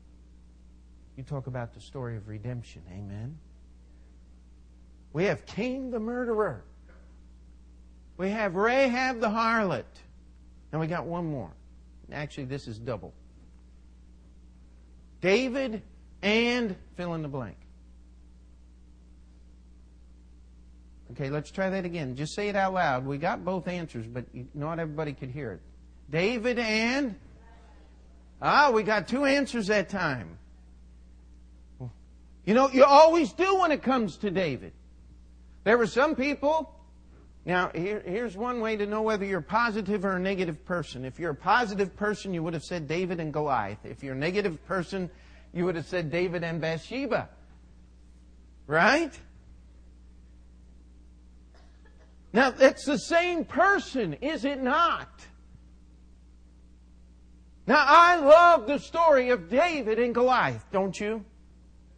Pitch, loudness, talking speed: 135 Hz, -26 LUFS, 130 wpm